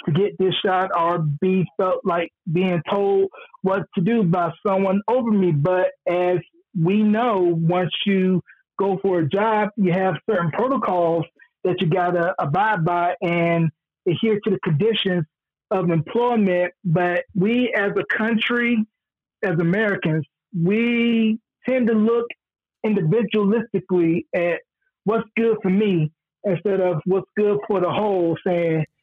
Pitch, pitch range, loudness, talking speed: 185 Hz, 175-215 Hz, -21 LUFS, 145 wpm